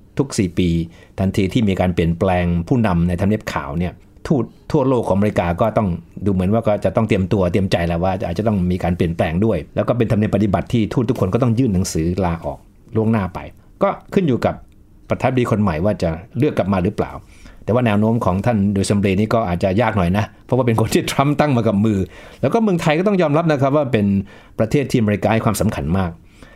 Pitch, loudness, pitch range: 105 Hz, -18 LUFS, 90-115 Hz